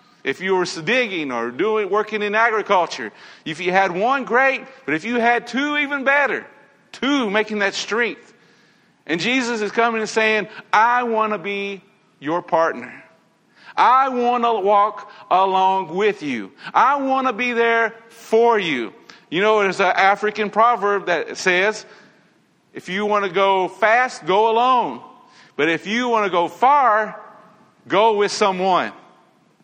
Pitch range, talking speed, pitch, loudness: 200-240 Hz, 155 wpm, 215 Hz, -19 LUFS